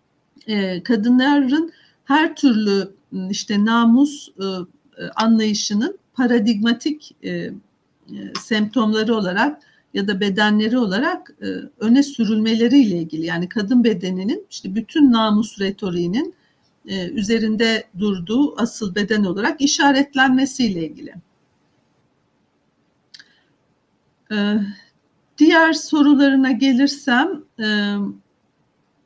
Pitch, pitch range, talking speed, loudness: 225 Hz, 205-275 Hz, 70 wpm, -18 LUFS